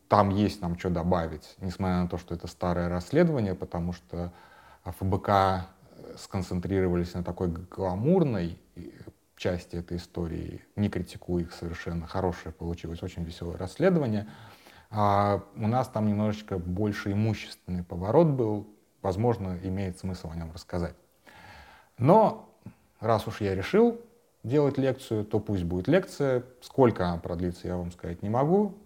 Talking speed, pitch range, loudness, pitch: 135 wpm, 90-110 Hz, -29 LUFS, 95 Hz